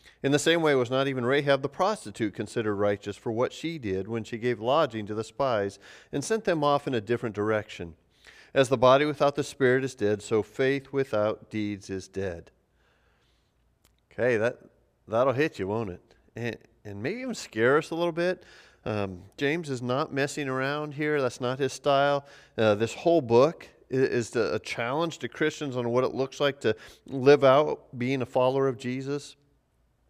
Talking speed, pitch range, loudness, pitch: 185 wpm, 110-145 Hz, -27 LUFS, 130 Hz